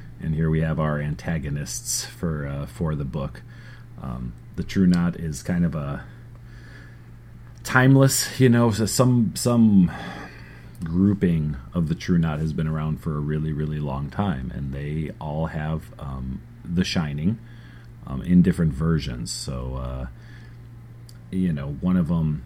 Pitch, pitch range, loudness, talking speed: 85 Hz, 75-115 Hz, -23 LUFS, 150 wpm